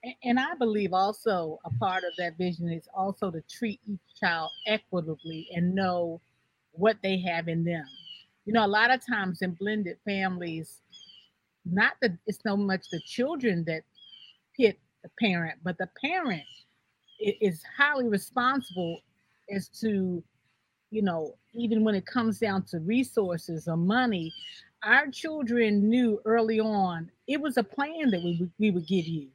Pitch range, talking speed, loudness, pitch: 170-225 Hz, 160 wpm, -28 LUFS, 195 Hz